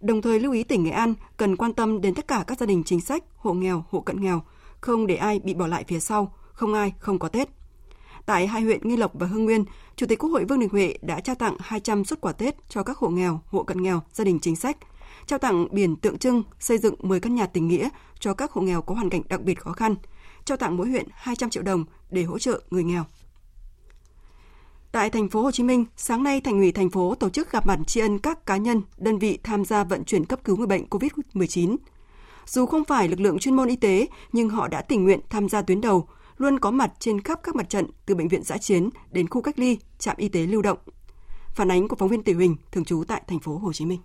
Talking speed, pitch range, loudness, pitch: 260 wpm, 180-230 Hz, -24 LUFS, 205 Hz